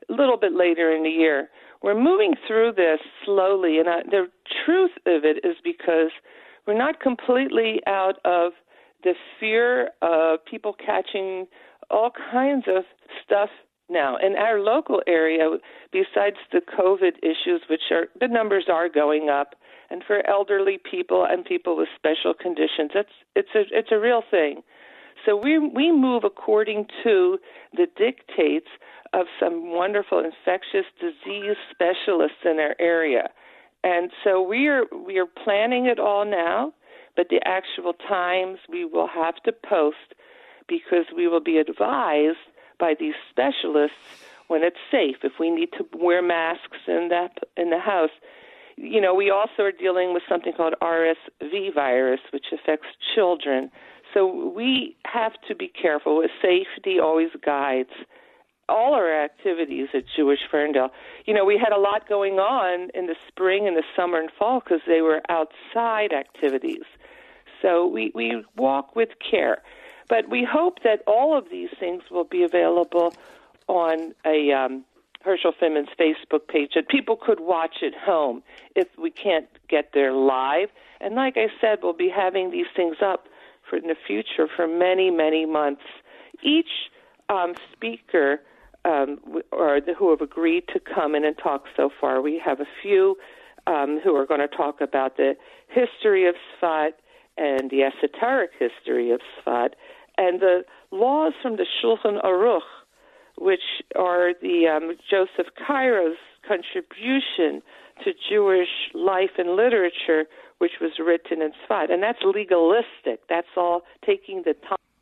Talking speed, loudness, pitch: 155 wpm, -23 LUFS, 190 Hz